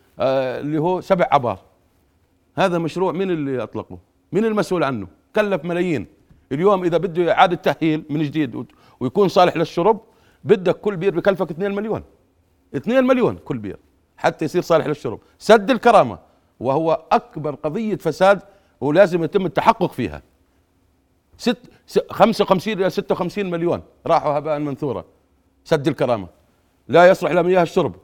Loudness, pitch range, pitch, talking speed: -19 LUFS, 135-195 Hz, 170 Hz, 135 wpm